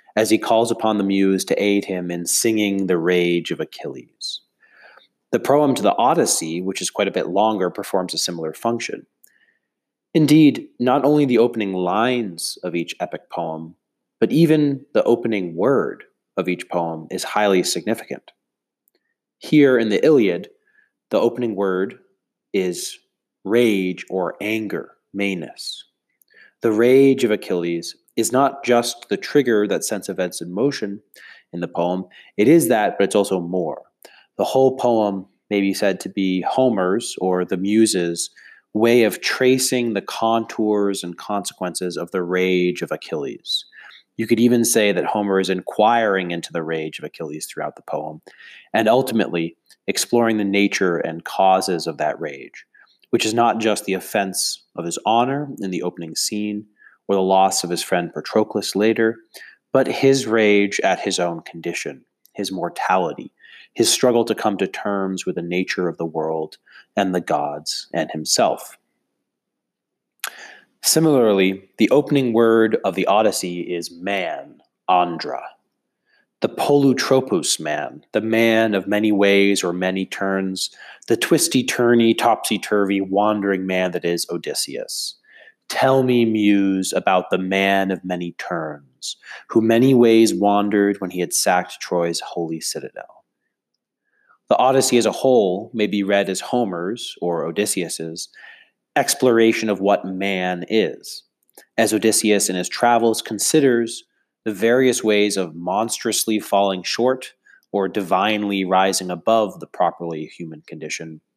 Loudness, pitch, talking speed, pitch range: -19 LUFS, 100 Hz, 145 wpm, 90-115 Hz